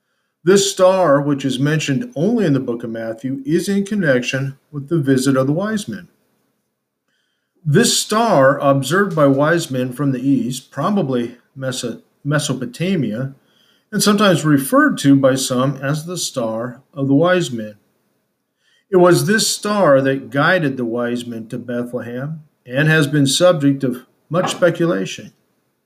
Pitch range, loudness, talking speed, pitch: 130-180 Hz, -17 LUFS, 145 wpm, 140 Hz